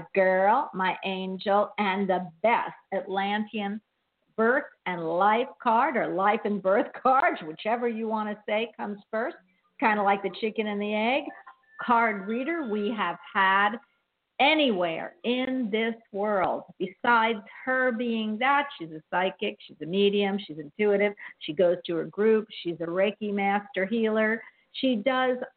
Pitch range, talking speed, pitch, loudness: 190-235 Hz, 155 wpm, 210 Hz, -26 LUFS